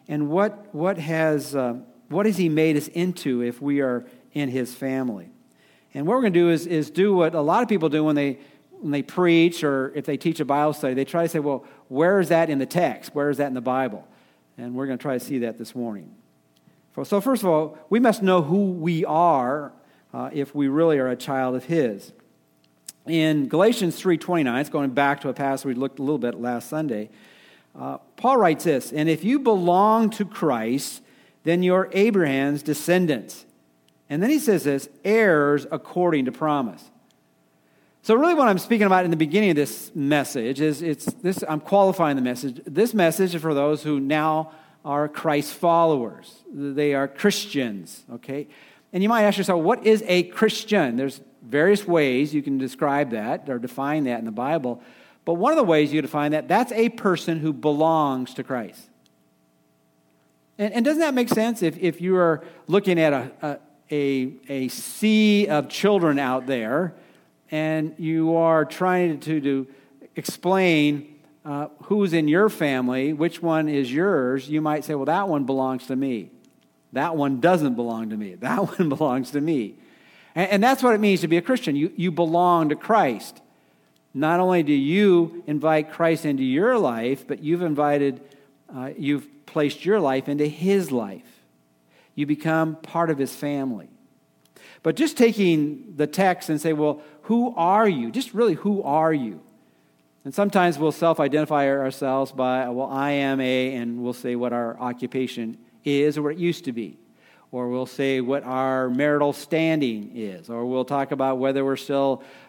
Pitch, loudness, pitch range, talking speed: 150 Hz, -22 LUFS, 135-175 Hz, 190 wpm